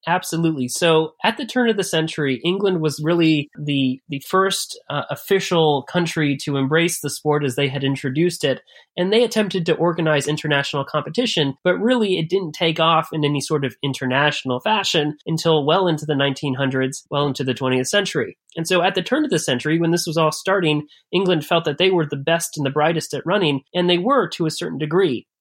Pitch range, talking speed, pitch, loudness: 145-180 Hz, 205 wpm, 160 Hz, -20 LUFS